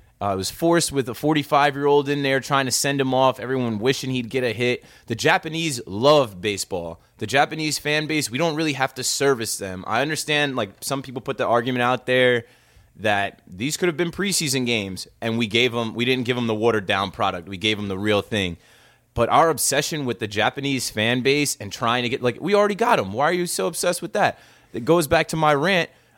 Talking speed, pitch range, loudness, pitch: 230 wpm, 115-150 Hz, -21 LUFS, 130 Hz